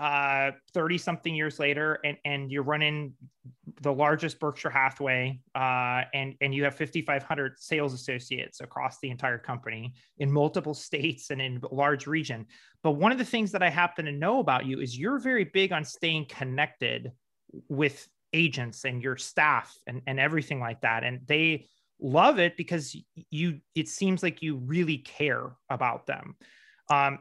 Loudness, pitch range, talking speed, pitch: -28 LUFS, 135-160 Hz, 170 wpm, 145 Hz